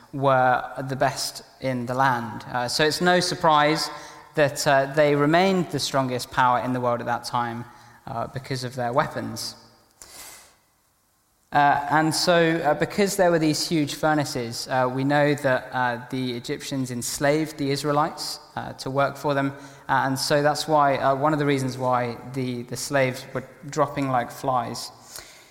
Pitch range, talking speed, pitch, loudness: 125-150 Hz, 165 wpm, 140 Hz, -23 LUFS